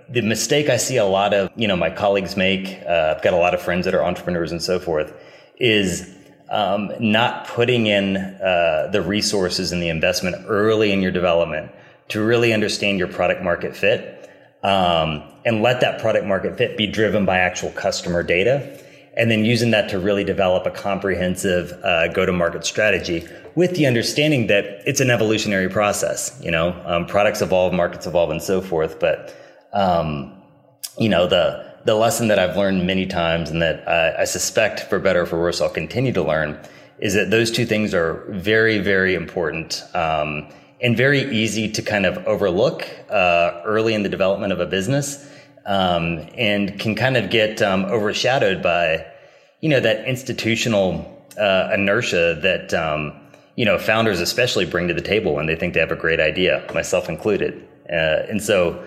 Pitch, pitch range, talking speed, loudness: 100 Hz, 90-110 Hz, 180 wpm, -19 LUFS